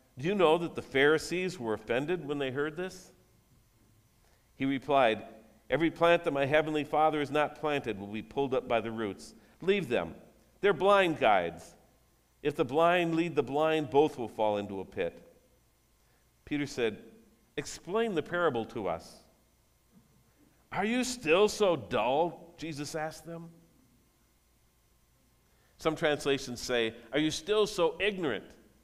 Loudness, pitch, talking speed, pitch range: -30 LUFS, 150 Hz, 145 wpm, 120-165 Hz